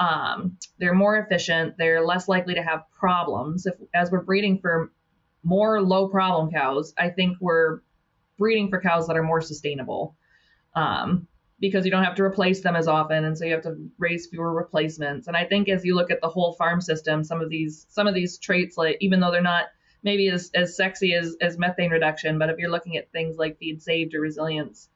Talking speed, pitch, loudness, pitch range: 215 wpm, 170 Hz, -24 LUFS, 160-185 Hz